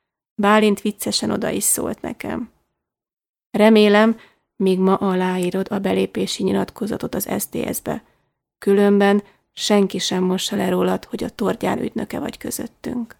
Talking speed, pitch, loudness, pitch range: 125 wpm, 200 Hz, -20 LUFS, 185-210 Hz